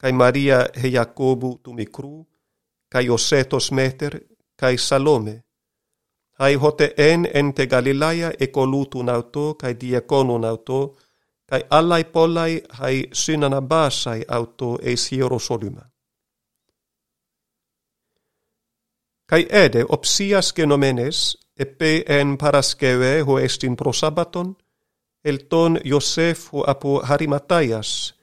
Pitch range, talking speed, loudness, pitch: 125-155 Hz, 100 wpm, -19 LUFS, 140 Hz